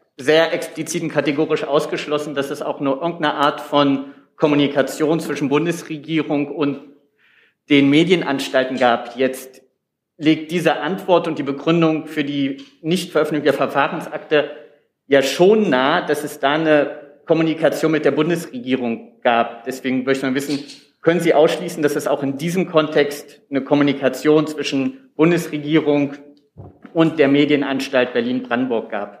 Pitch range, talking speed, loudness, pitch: 135-155 Hz, 135 wpm, -18 LUFS, 145 Hz